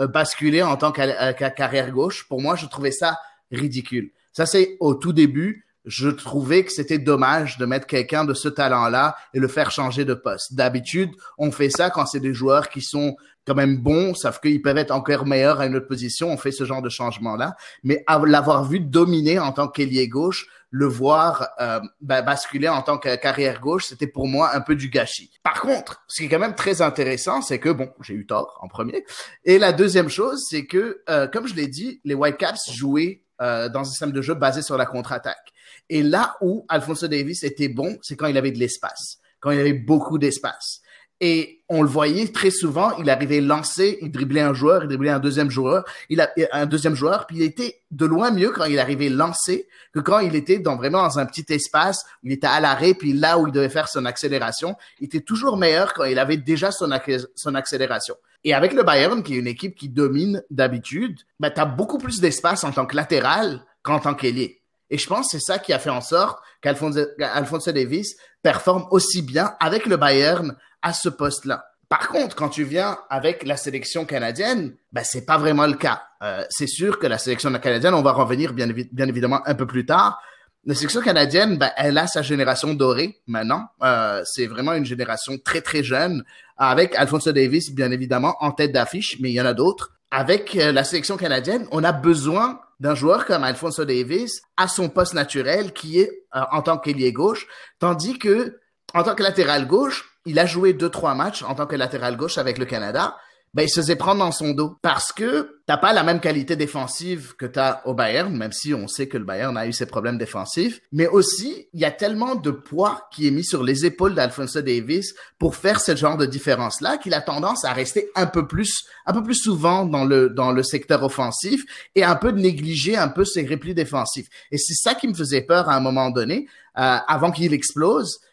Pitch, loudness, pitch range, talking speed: 150 Hz, -21 LUFS, 135-170 Hz, 220 wpm